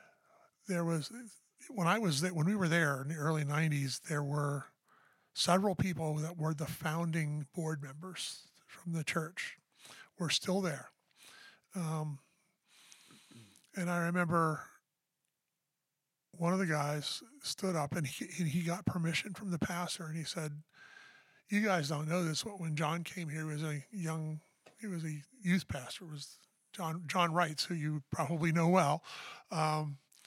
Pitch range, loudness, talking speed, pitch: 155-180 Hz, -36 LUFS, 165 wpm, 165 Hz